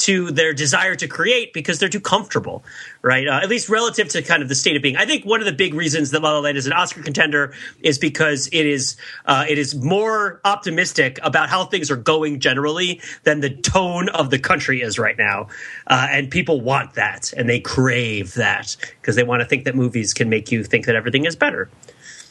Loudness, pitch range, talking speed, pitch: -18 LUFS, 135-180 Hz, 225 wpm, 150 Hz